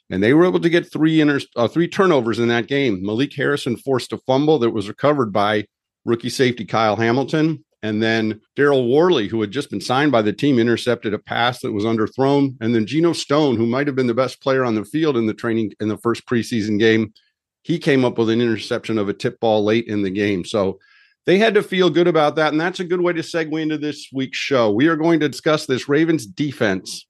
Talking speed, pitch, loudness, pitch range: 240 wpm, 130 Hz, -19 LUFS, 110-155 Hz